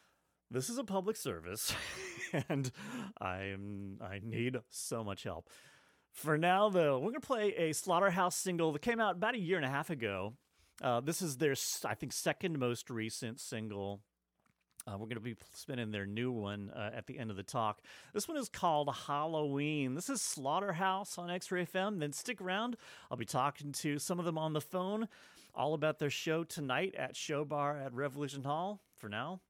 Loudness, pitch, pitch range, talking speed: -37 LUFS, 145 Hz, 115-185 Hz, 195 wpm